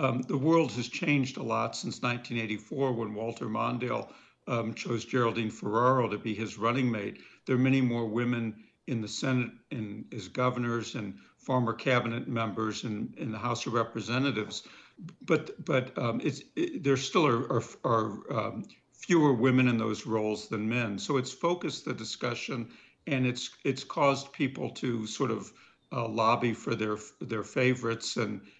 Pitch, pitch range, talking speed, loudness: 120 Hz, 110-130 Hz, 170 wpm, -30 LUFS